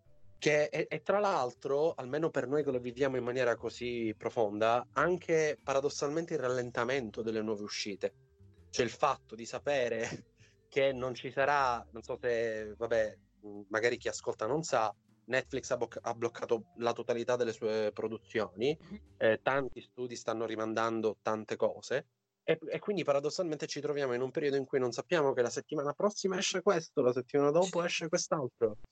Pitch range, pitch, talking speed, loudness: 115-150 Hz, 125 Hz, 170 wpm, -33 LUFS